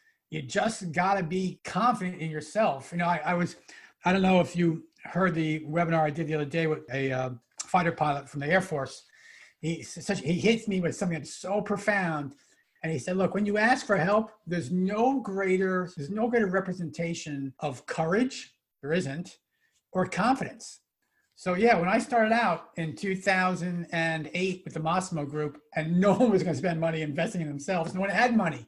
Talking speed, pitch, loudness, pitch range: 190 wpm, 180 Hz, -28 LUFS, 160-200 Hz